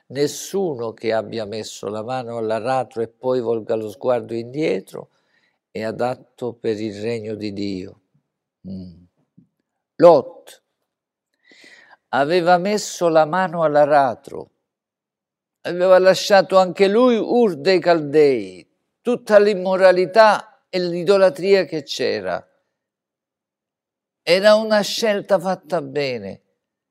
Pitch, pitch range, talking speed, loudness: 160 Hz, 115-190 Hz, 100 wpm, -18 LUFS